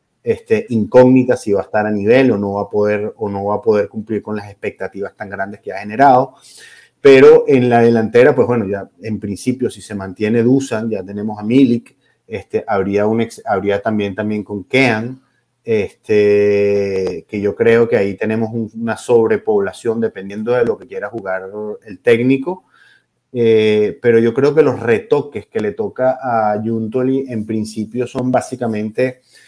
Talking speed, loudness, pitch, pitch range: 175 wpm, -15 LUFS, 110 Hz, 105-130 Hz